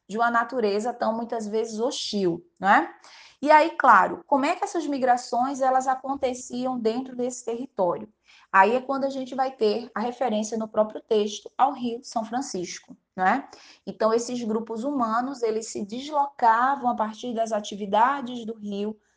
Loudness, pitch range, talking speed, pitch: -25 LUFS, 220-260 Hz, 160 wpm, 235 Hz